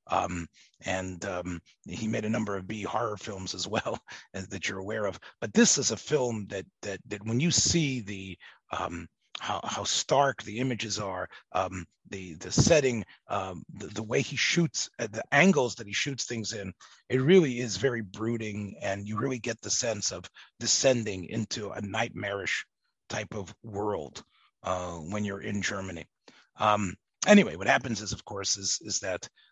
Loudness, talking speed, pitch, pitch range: -29 LUFS, 180 wpm, 105 Hz, 95-120 Hz